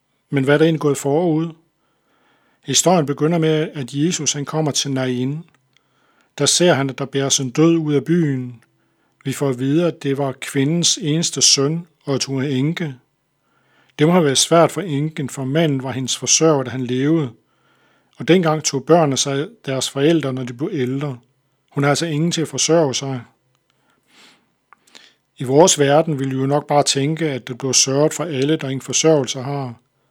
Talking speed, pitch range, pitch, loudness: 190 wpm, 135-160 Hz, 140 Hz, -18 LUFS